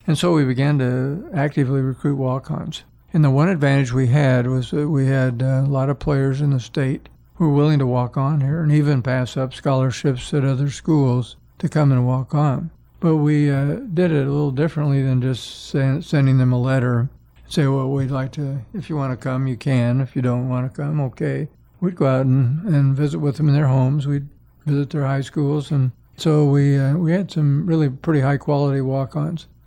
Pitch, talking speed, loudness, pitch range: 140 Hz, 220 wpm, -19 LUFS, 130-150 Hz